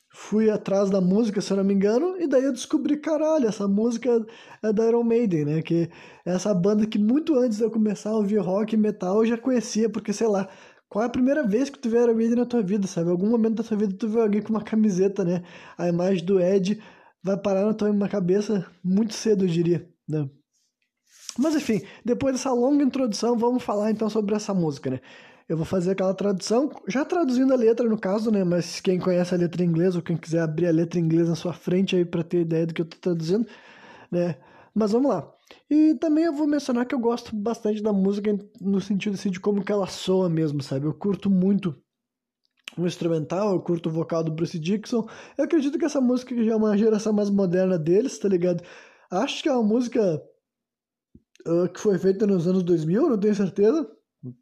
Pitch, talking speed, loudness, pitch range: 205 Hz, 220 wpm, -24 LUFS, 180-235 Hz